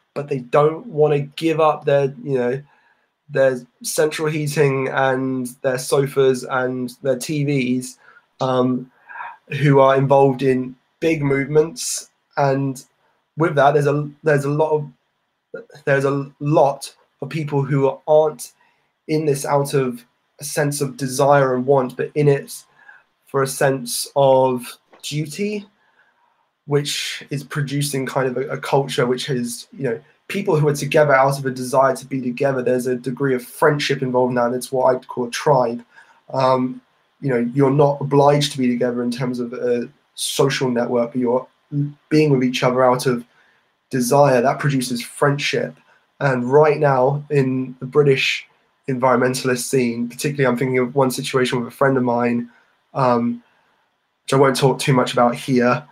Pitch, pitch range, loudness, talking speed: 135 Hz, 125-145 Hz, -19 LUFS, 165 wpm